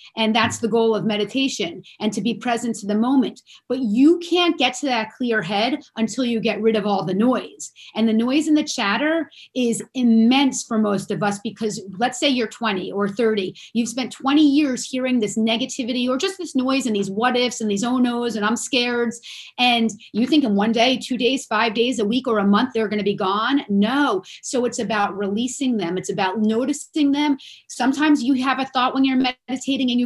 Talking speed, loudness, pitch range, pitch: 220 wpm, -20 LUFS, 215-260 Hz, 240 Hz